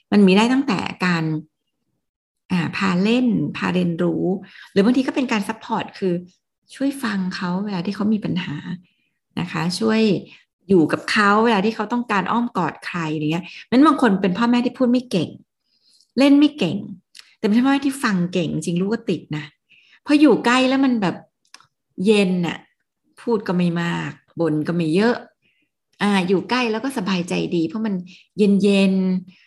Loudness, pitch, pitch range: -20 LUFS, 200 Hz, 180-235 Hz